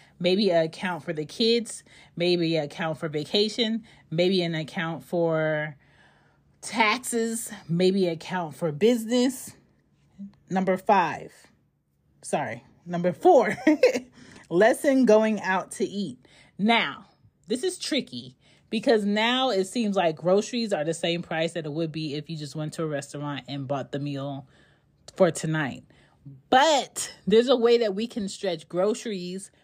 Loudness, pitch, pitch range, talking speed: -25 LUFS, 180 Hz, 155-215 Hz, 145 wpm